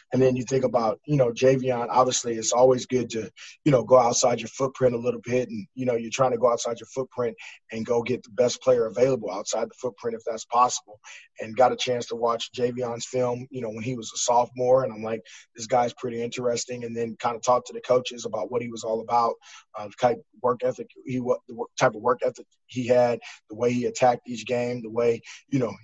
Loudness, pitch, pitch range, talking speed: -25 LUFS, 125 Hz, 115-125 Hz, 245 wpm